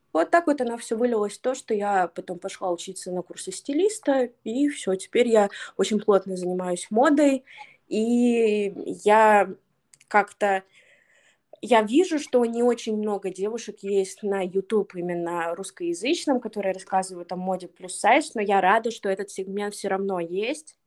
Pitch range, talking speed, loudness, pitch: 190-240 Hz, 150 wpm, -24 LUFS, 205 Hz